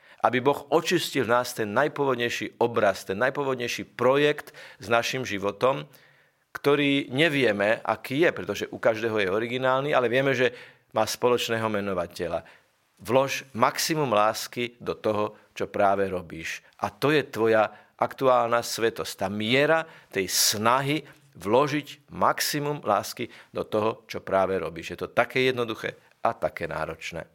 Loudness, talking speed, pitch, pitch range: -25 LUFS, 135 wpm, 120 Hz, 110-140 Hz